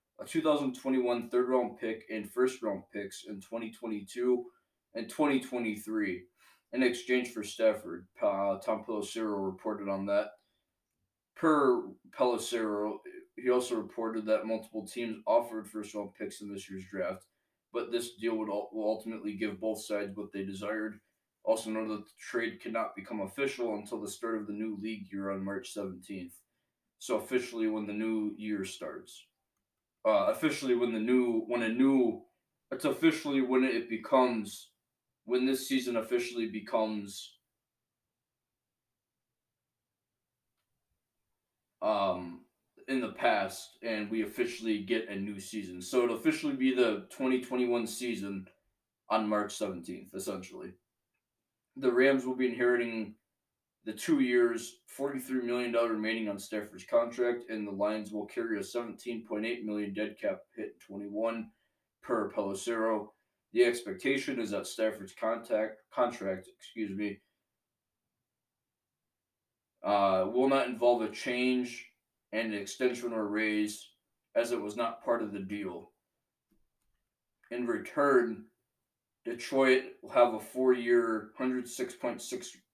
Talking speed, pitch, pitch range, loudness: 130 wpm, 115 Hz, 105-125 Hz, -33 LUFS